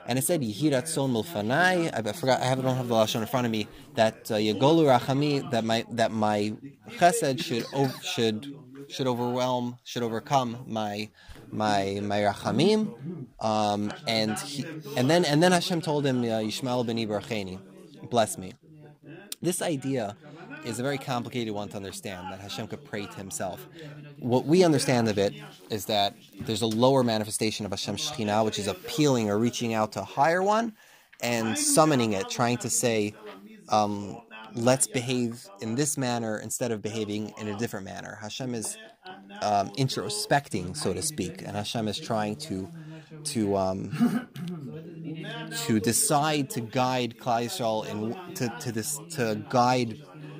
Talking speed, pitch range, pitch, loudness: 160 wpm, 110-140 Hz, 120 Hz, -27 LUFS